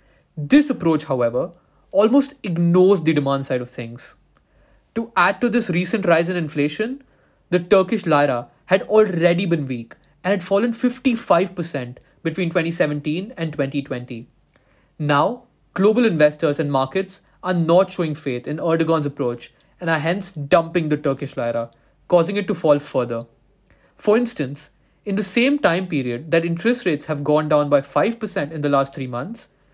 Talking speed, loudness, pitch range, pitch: 155 wpm, -20 LUFS, 145-195 Hz, 165 Hz